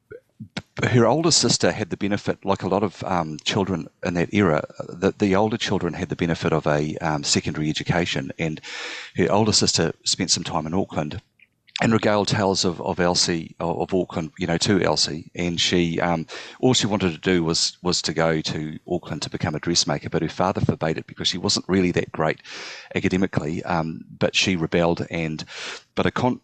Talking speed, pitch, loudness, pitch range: 195 wpm, 85 Hz, -22 LUFS, 80-100 Hz